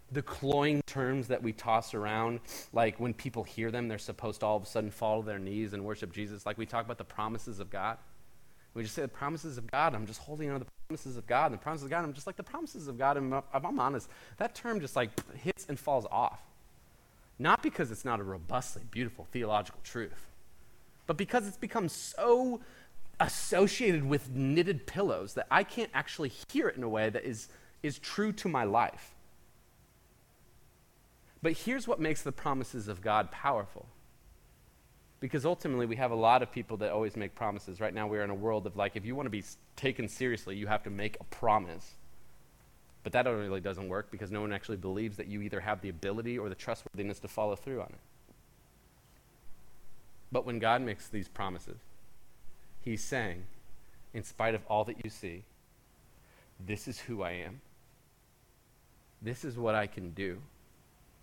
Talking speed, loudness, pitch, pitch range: 200 wpm, -34 LUFS, 115 Hz, 105-140 Hz